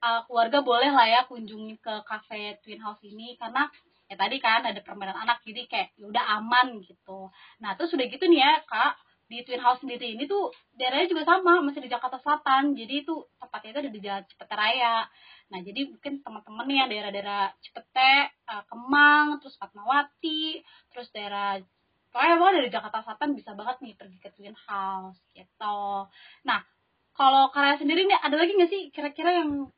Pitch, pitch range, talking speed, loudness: 245 Hz, 210-290 Hz, 175 wpm, -25 LUFS